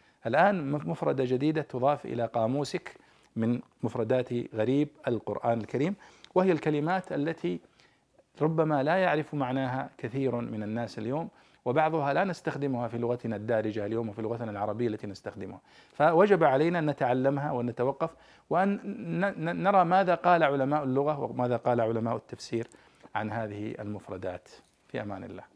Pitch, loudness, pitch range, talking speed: 130 Hz, -29 LUFS, 115-155 Hz, 130 wpm